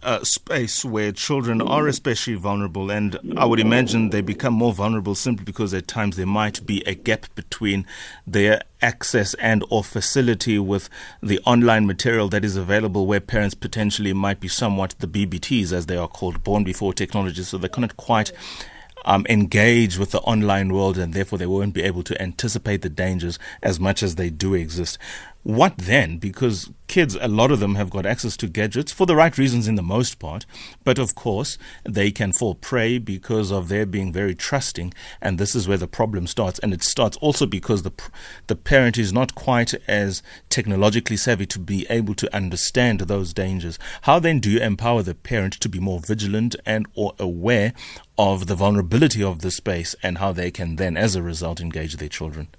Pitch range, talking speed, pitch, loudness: 95-115 Hz, 195 wpm, 100 Hz, -21 LUFS